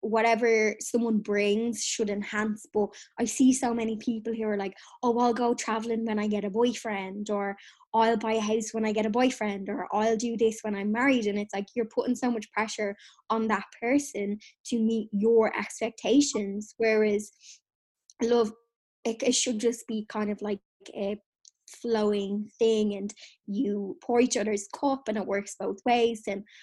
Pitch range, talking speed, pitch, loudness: 210-235 Hz, 180 wpm, 220 Hz, -28 LUFS